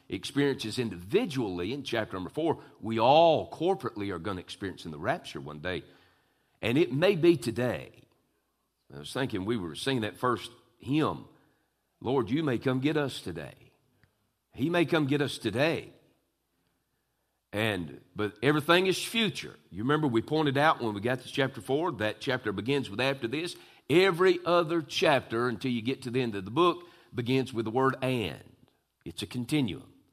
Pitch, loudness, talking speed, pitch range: 130 Hz, -29 LUFS, 175 wpm, 110-150 Hz